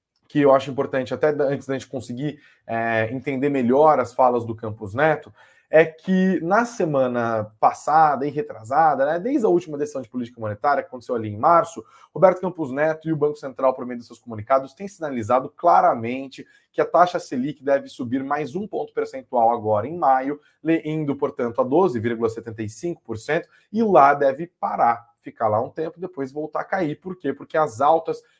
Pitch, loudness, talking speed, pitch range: 145 Hz, -22 LUFS, 185 wpm, 125-160 Hz